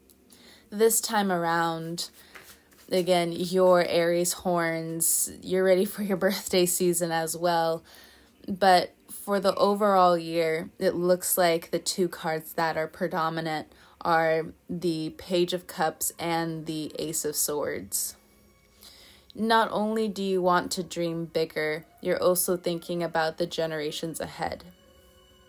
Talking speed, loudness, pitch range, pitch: 125 wpm, -26 LUFS, 165-185 Hz, 170 Hz